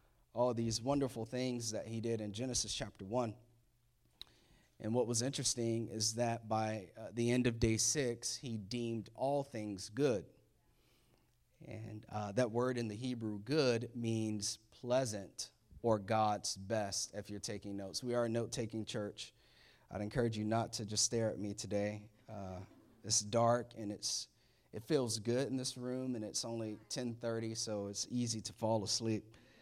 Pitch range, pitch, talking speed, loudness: 105-120 Hz, 115 Hz, 170 wpm, -38 LUFS